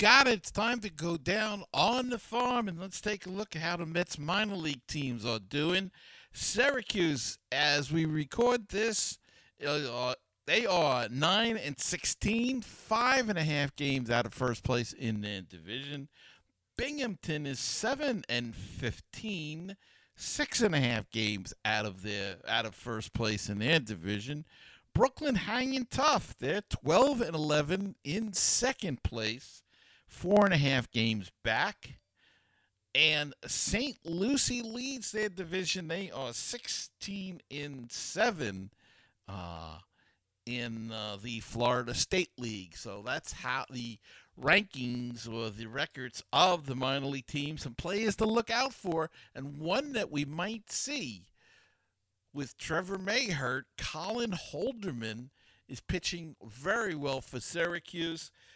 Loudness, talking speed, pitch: -32 LUFS, 140 wpm, 150 Hz